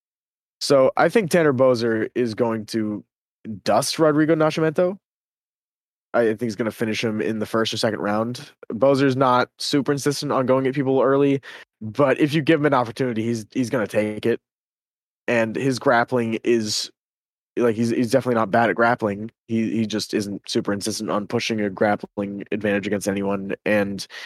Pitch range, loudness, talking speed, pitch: 110-135 Hz, -21 LUFS, 175 wpm, 115 Hz